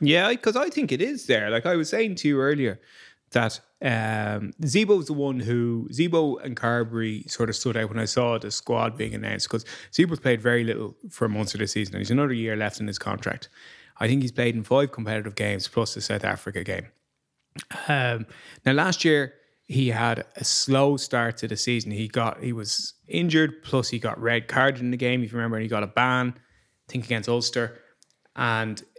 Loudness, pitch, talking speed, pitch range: -25 LUFS, 120 Hz, 215 wpm, 110-135 Hz